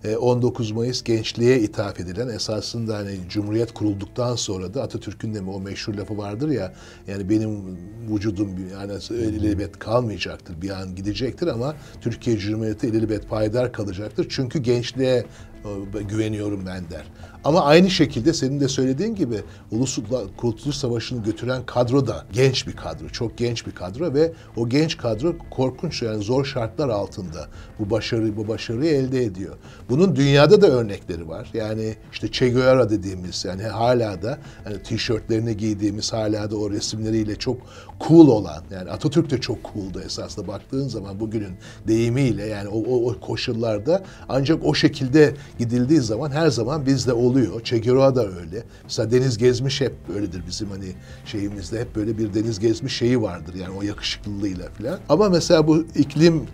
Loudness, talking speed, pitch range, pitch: -22 LUFS, 160 wpm, 105-130 Hz, 110 Hz